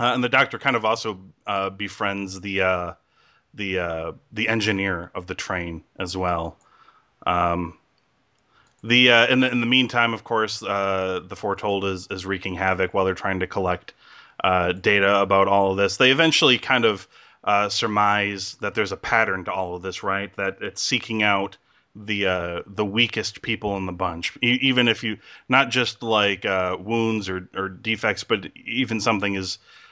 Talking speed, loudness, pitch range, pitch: 180 wpm, -22 LUFS, 95-115 Hz, 100 Hz